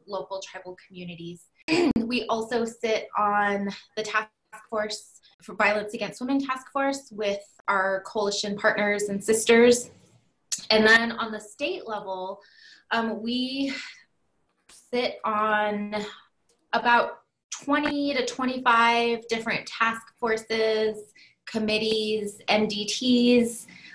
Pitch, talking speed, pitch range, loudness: 220 Hz, 105 wpm, 210-235 Hz, -25 LUFS